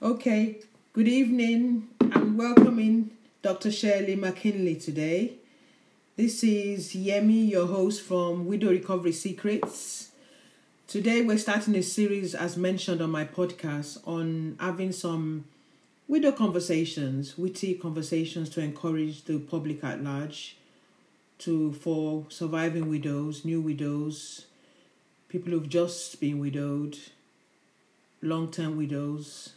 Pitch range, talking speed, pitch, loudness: 155-210 Hz, 110 wpm, 180 Hz, -28 LUFS